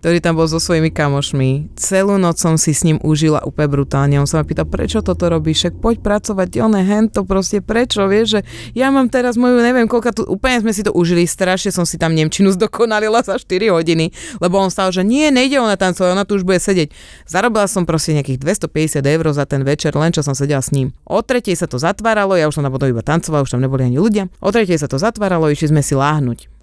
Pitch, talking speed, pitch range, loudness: 175 Hz, 235 wpm, 155-210 Hz, -15 LUFS